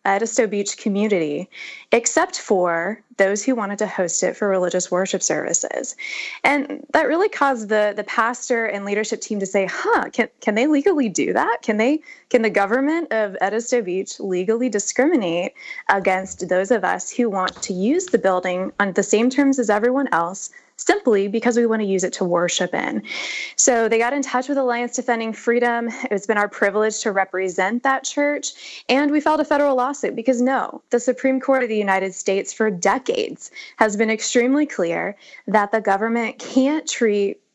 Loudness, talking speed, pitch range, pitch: -20 LUFS, 180 wpm, 200-260 Hz, 225 Hz